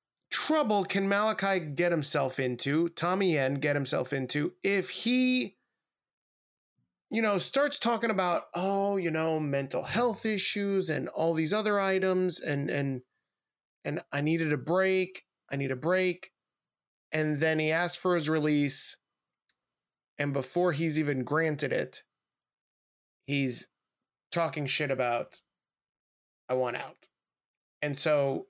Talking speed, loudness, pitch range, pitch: 130 wpm, -29 LUFS, 140-190 Hz, 160 Hz